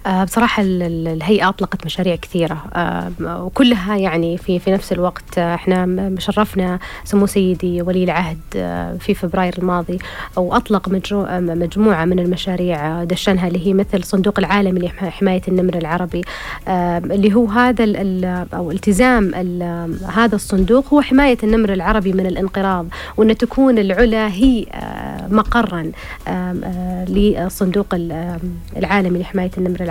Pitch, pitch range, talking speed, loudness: 185 Hz, 180-205 Hz, 115 wpm, -17 LUFS